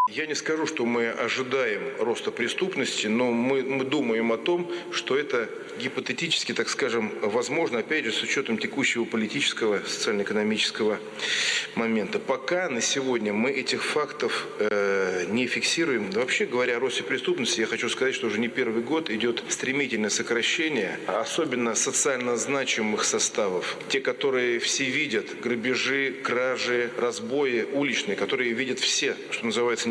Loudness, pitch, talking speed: -26 LUFS, 130 Hz, 140 wpm